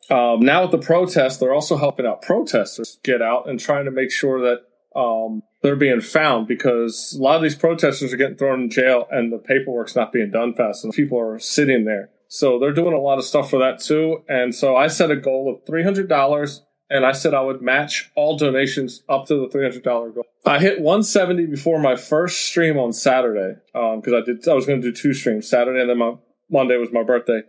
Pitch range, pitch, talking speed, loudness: 120-150 Hz, 135 Hz, 240 wpm, -19 LUFS